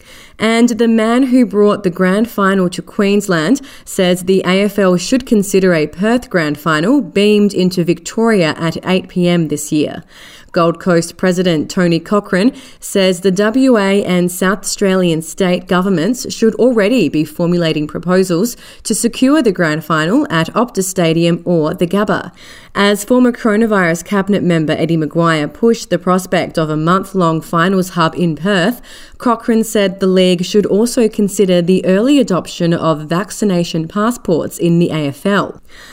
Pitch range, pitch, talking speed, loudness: 170-210 Hz, 185 Hz, 145 wpm, -13 LUFS